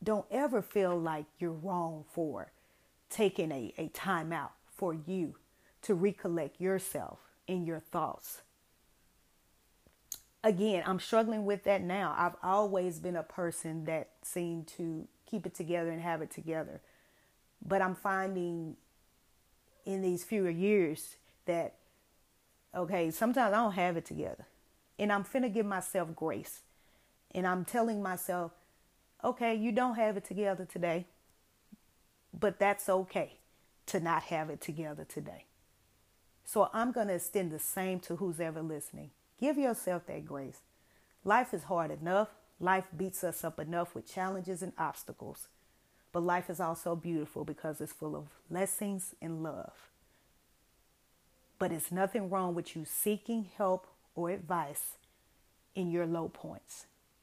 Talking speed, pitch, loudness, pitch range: 145 wpm, 180 Hz, -35 LUFS, 165-195 Hz